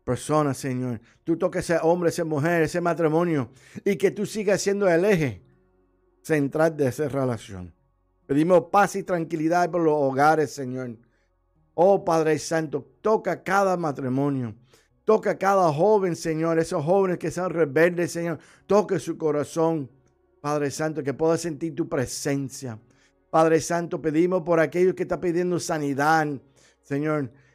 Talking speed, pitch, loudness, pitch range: 140 wpm, 160 Hz, -24 LUFS, 140-175 Hz